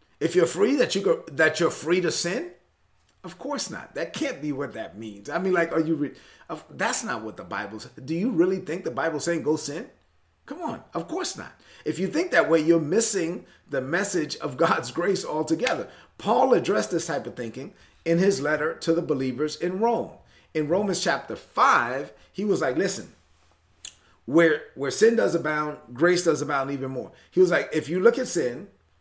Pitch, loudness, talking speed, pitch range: 160 Hz, -25 LUFS, 205 wpm, 135-175 Hz